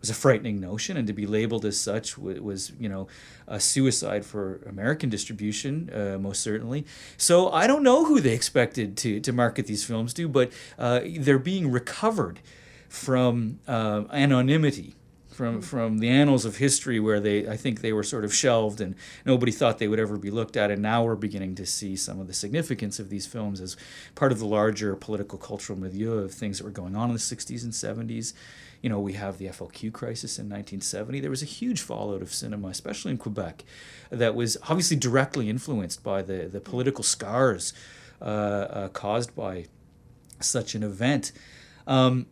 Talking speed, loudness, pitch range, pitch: 190 wpm, -26 LUFS, 105-130 Hz, 115 Hz